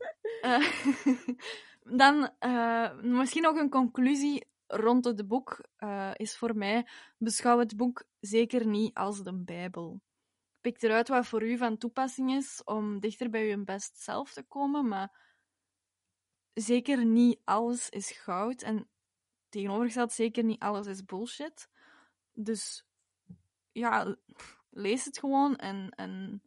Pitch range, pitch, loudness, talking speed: 205-250 Hz, 230 Hz, -31 LUFS, 135 wpm